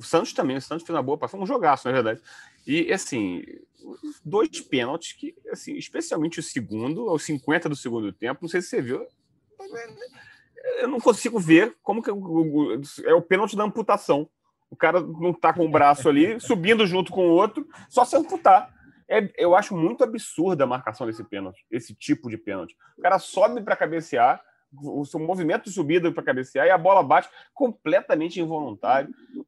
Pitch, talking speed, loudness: 200 Hz, 190 wpm, -23 LUFS